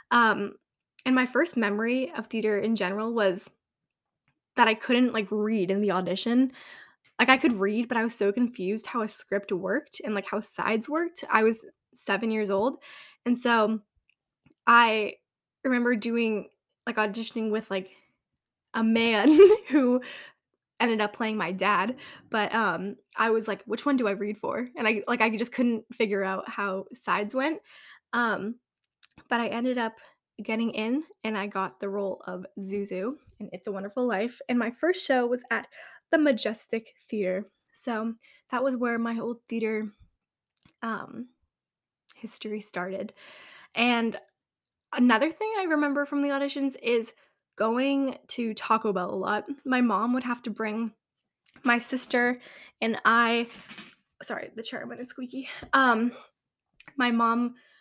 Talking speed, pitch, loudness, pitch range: 155 wpm, 230 Hz, -27 LUFS, 210-250 Hz